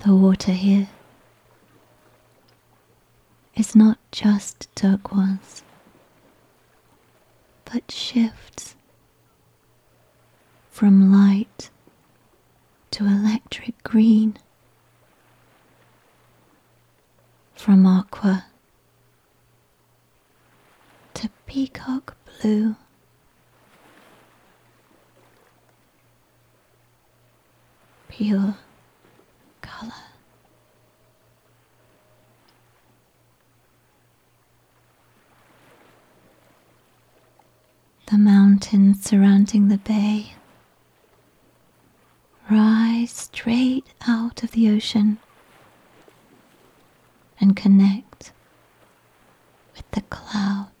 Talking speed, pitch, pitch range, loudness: 45 wpm, 205 Hz, 190-220 Hz, -19 LUFS